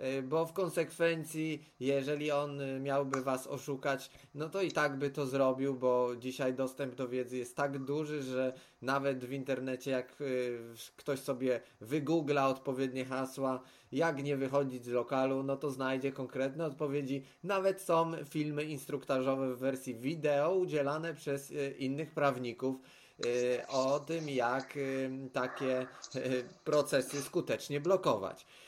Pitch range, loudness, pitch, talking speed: 130-150 Hz, -35 LUFS, 135 Hz, 130 wpm